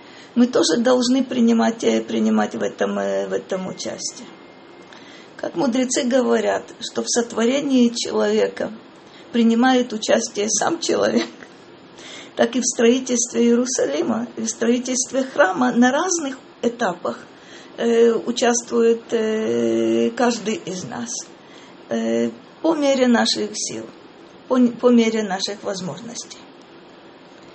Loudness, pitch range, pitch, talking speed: -20 LUFS, 215-255 Hz, 235 Hz, 100 wpm